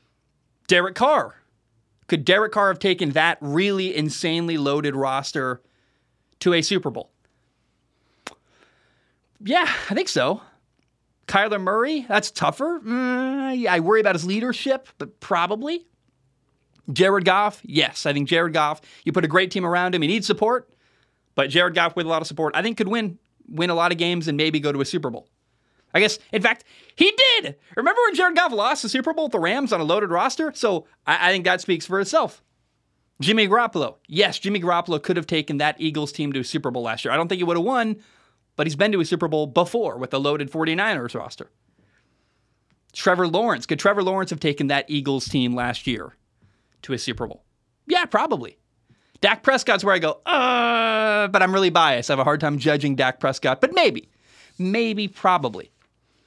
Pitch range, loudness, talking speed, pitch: 150-215 Hz, -21 LUFS, 190 wpm, 175 Hz